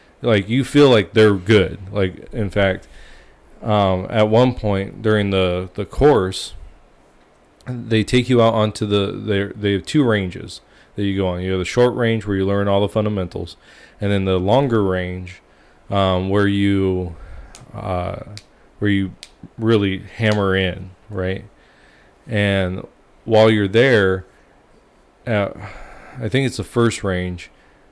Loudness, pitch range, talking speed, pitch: -18 LUFS, 95-110 Hz, 150 wpm, 100 Hz